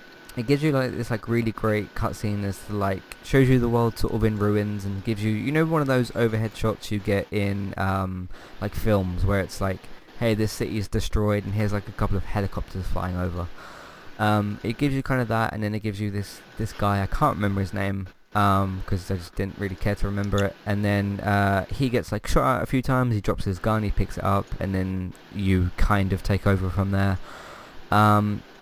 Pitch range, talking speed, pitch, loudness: 95-110 Hz, 235 wpm, 105 Hz, -25 LUFS